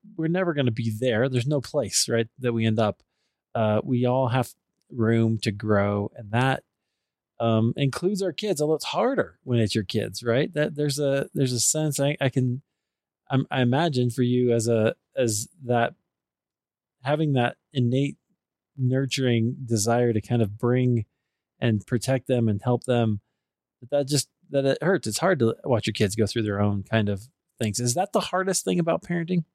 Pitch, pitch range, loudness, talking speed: 125 Hz, 115-140 Hz, -25 LUFS, 190 wpm